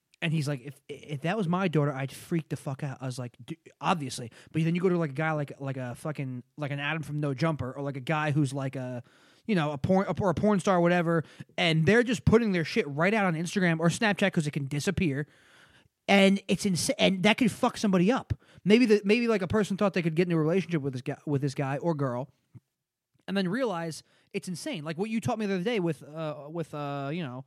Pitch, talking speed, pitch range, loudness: 160 Hz, 260 wpm, 145-190 Hz, -28 LUFS